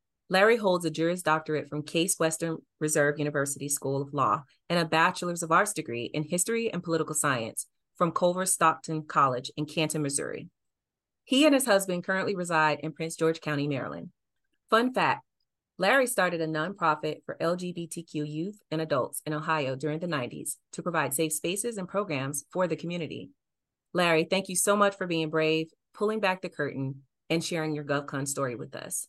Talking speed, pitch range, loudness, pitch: 175 wpm, 150-180 Hz, -28 LUFS, 160 Hz